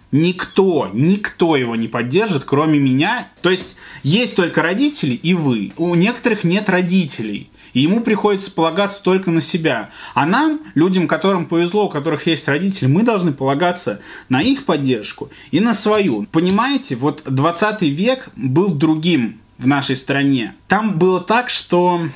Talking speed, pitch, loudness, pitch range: 150 wpm, 175 Hz, -17 LUFS, 145-200 Hz